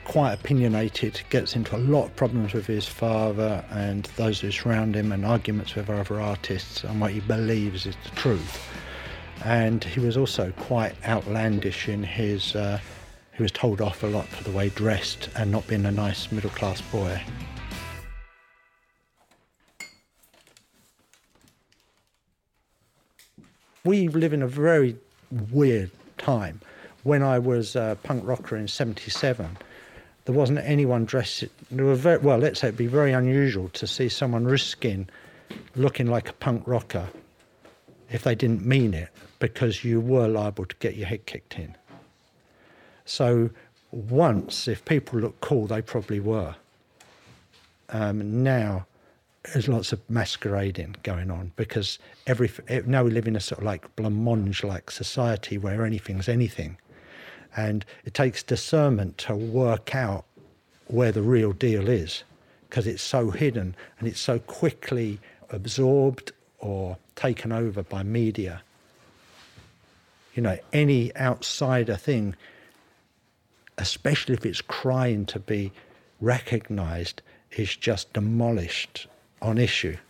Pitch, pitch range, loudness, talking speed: 110 Hz, 100-125 Hz, -26 LUFS, 140 wpm